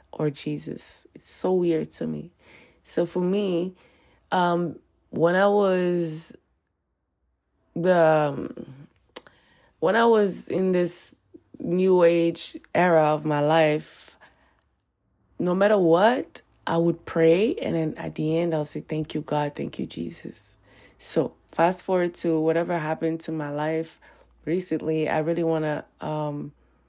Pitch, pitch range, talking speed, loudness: 160 Hz, 150-175 Hz, 135 wpm, -24 LUFS